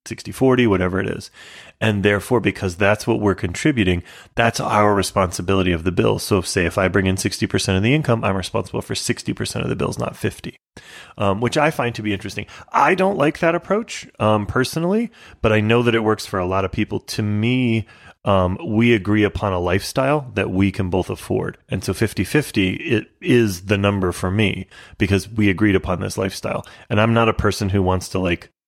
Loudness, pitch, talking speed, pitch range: -19 LUFS, 105 Hz, 210 wpm, 95-115 Hz